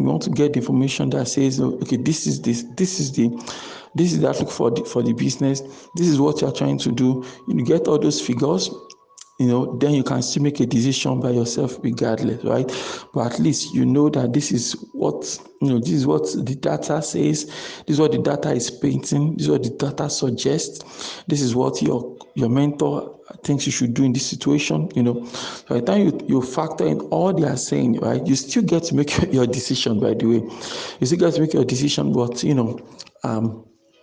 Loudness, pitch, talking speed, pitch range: -21 LUFS, 130 Hz, 225 wpm, 120-145 Hz